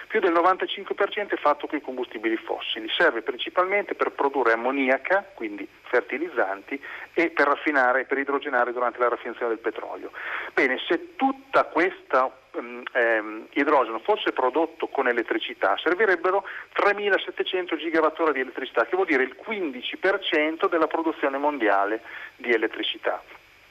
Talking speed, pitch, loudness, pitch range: 135 wpm, 170 Hz, -24 LUFS, 130-210 Hz